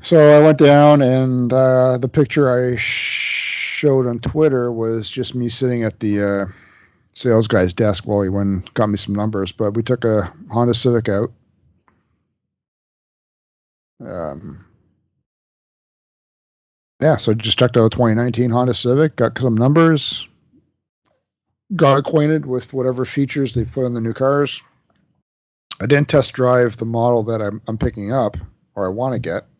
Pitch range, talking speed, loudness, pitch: 110-130 Hz, 160 wpm, -17 LUFS, 120 Hz